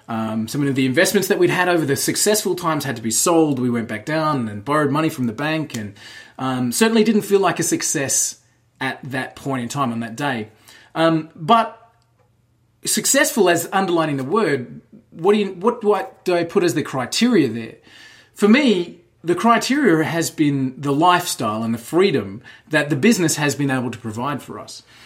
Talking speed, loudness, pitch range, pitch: 200 wpm, -19 LUFS, 125-185 Hz, 155 Hz